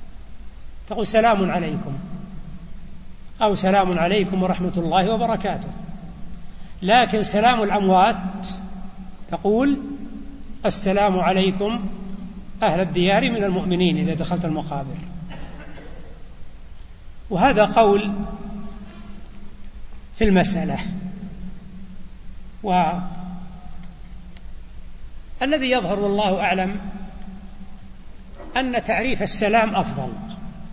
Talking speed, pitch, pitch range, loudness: 65 wpm, 190 Hz, 180-205 Hz, -20 LUFS